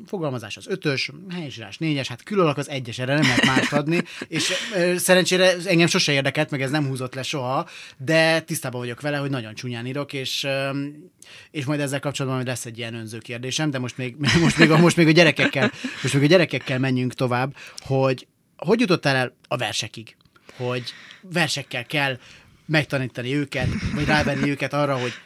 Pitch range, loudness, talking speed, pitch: 125-160 Hz, -22 LUFS, 190 wpm, 140 Hz